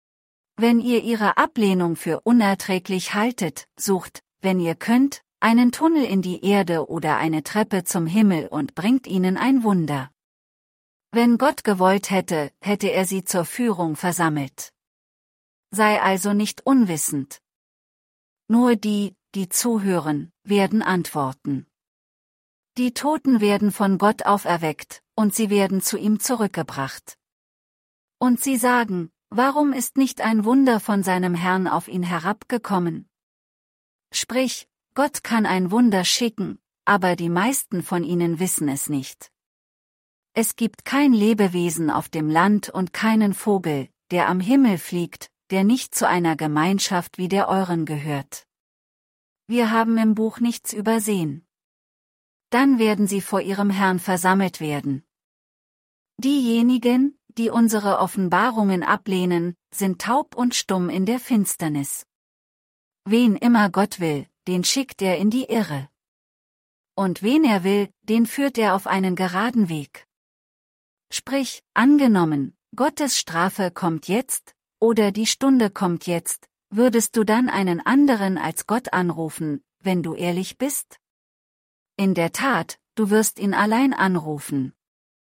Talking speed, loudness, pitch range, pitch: 130 wpm, -21 LUFS, 175-230 Hz, 195 Hz